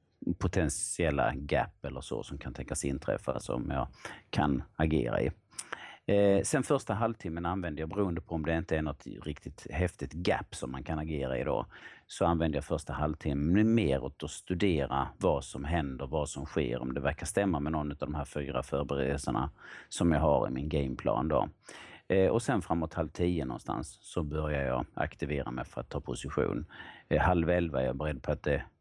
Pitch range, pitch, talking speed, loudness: 70-85 Hz, 75 Hz, 195 wpm, -32 LUFS